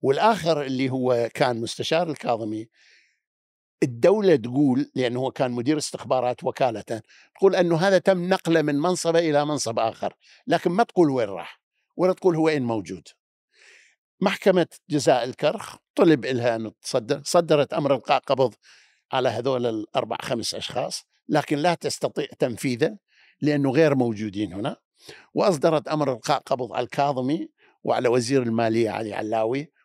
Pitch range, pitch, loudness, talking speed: 120-165 Hz, 140 Hz, -23 LUFS, 135 wpm